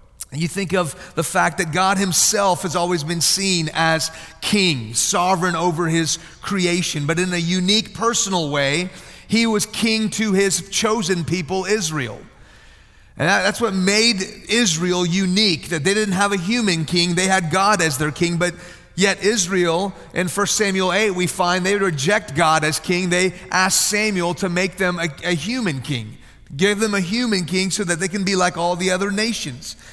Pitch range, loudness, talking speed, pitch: 170-200 Hz, -19 LUFS, 180 wpm, 185 Hz